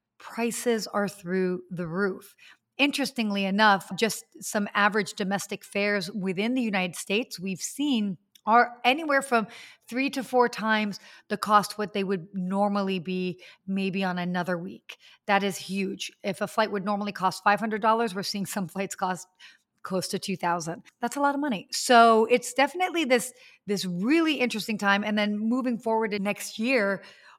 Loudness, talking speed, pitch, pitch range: -26 LUFS, 160 wpm, 205 Hz, 195-230 Hz